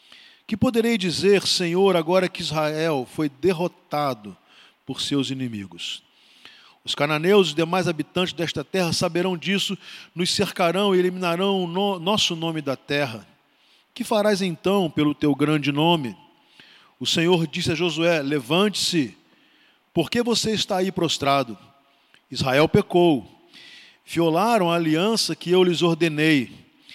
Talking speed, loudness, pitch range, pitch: 135 wpm, -22 LUFS, 150-190 Hz, 170 Hz